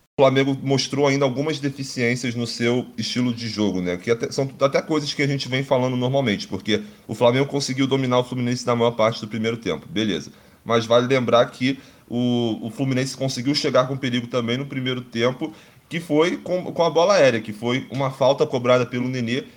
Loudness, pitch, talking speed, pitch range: -22 LUFS, 125 Hz, 200 wpm, 120-135 Hz